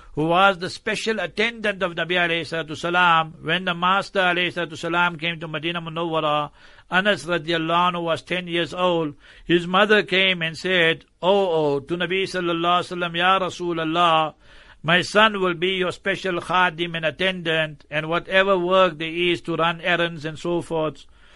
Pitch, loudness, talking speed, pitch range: 175 Hz, -21 LUFS, 155 wpm, 165-185 Hz